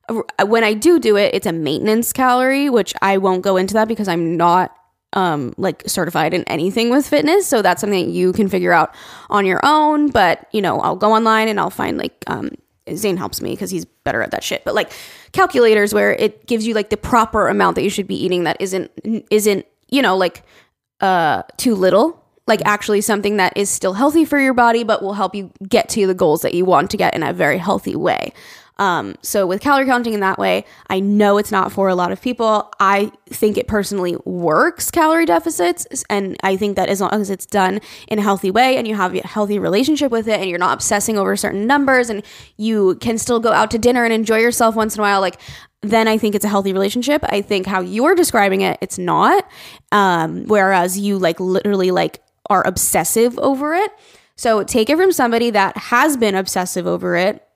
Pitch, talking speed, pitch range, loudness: 210 Hz, 220 wpm, 190-230 Hz, -16 LUFS